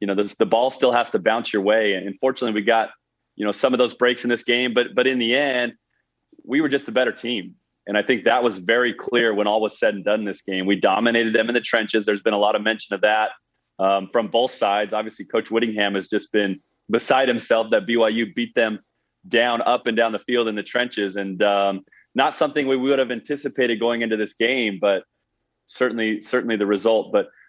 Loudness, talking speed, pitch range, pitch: -21 LUFS, 235 wpm, 105-120 Hz, 115 Hz